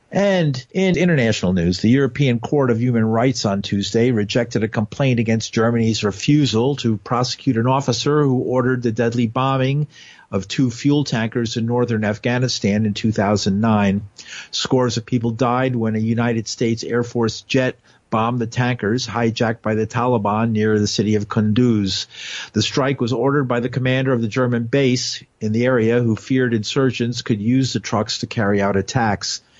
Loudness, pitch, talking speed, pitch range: -19 LUFS, 120 Hz, 170 wpm, 110-130 Hz